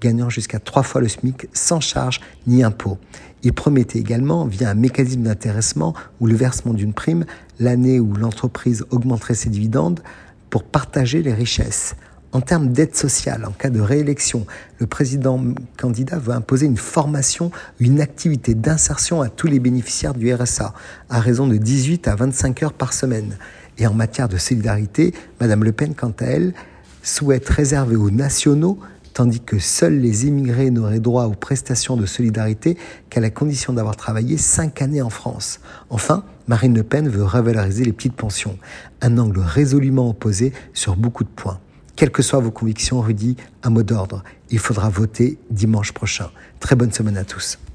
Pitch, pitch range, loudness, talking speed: 120 Hz, 110-135 Hz, -18 LUFS, 170 wpm